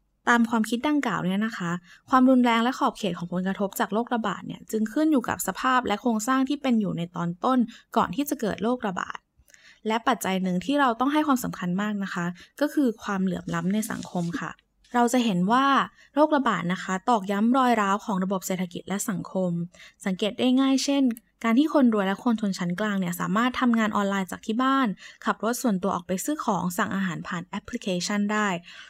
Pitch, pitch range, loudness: 215 Hz, 190-250 Hz, -25 LUFS